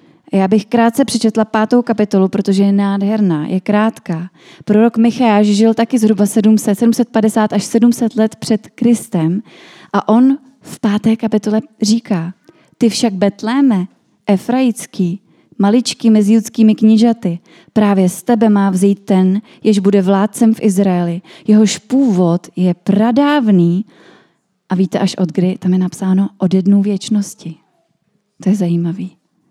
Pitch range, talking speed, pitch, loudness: 190-225 Hz, 135 wpm, 205 Hz, -13 LUFS